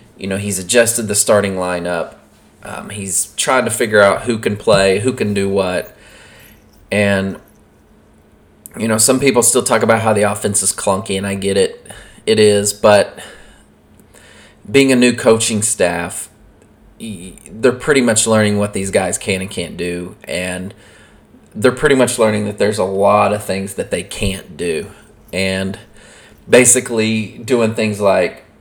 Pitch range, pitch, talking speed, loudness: 95-110 Hz, 105 Hz, 160 wpm, -15 LUFS